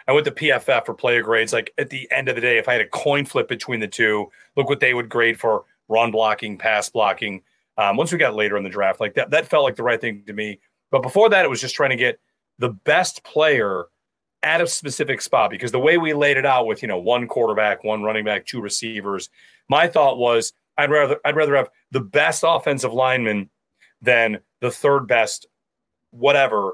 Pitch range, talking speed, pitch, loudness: 105-135 Hz, 225 wpm, 115 Hz, -19 LUFS